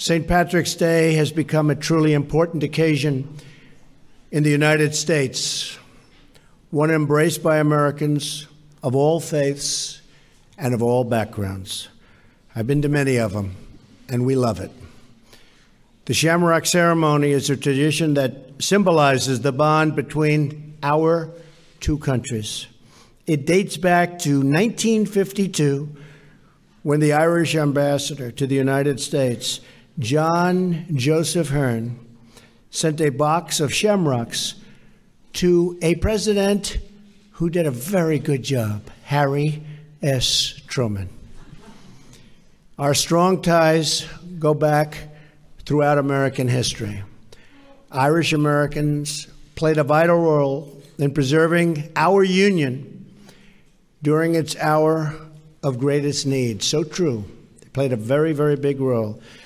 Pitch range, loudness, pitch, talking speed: 135-160 Hz, -20 LUFS, 150 Hz, 115 wpm